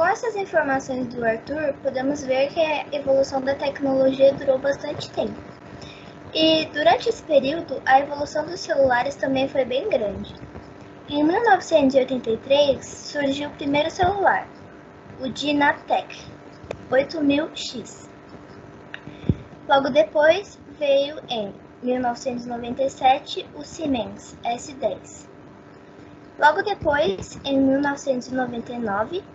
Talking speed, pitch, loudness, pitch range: 100 wpm, 280 Hz, -22 LUFS, 265-310 Hz